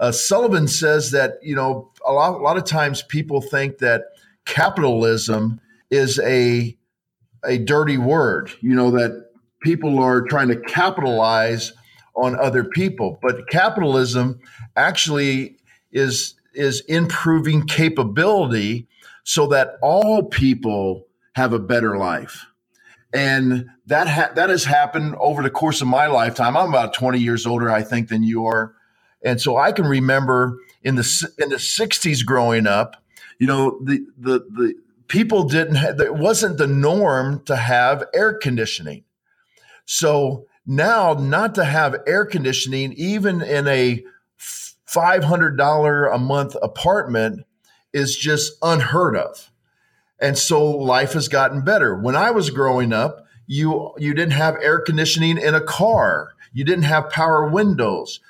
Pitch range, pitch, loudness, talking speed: 125-155 Hz, 140 Hz, -18 LUFS, 145 wpm